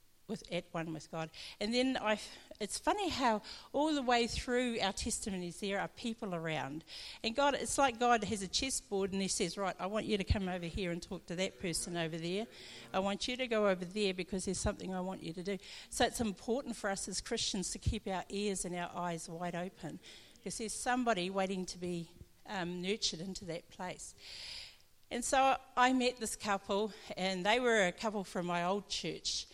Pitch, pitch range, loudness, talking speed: 200 Hz, 180-230 Hz, -36 LUFS, 215 wpm